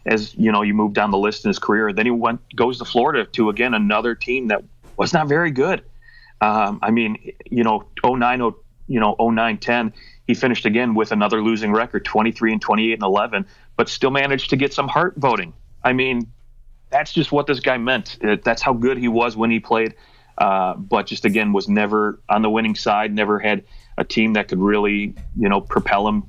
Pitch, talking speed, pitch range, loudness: 115 Hz, 220 wpm, 105-120 Hz, -19 LUFS